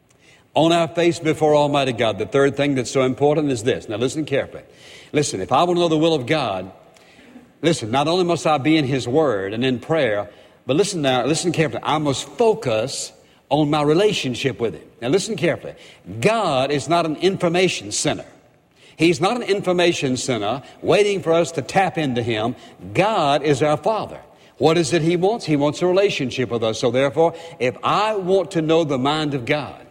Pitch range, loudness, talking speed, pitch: 135-170 Hz, -20 LUFS, 200 wpm, 150 Hz